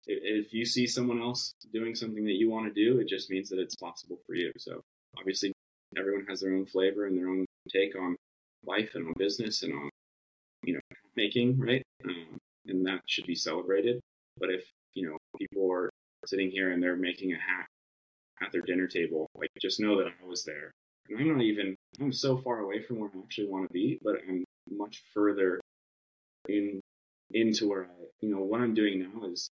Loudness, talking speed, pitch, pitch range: -32 LUFS, 205 wpm, 95 Hz, 90-110 Hz